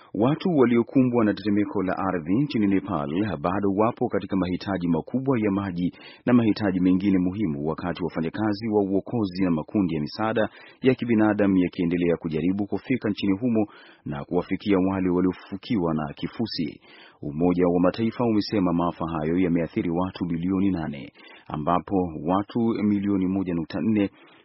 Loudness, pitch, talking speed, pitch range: -24 LUFS, 95 Hz, 135 wpm, 90-105 Hz